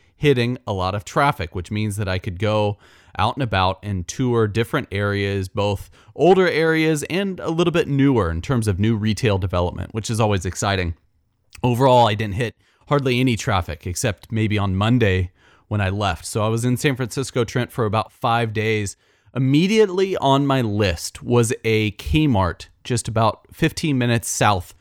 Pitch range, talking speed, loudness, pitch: 100-125 Hz, 175 wpm, -20 LUFS, 110 Hz